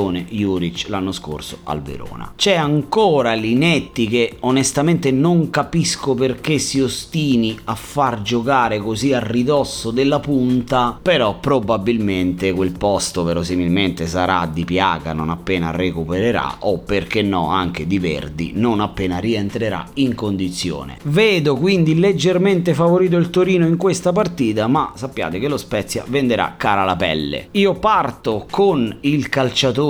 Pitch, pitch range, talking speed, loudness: 115 Hz, 95-145 Hz, 135 wpm, -18 LUFS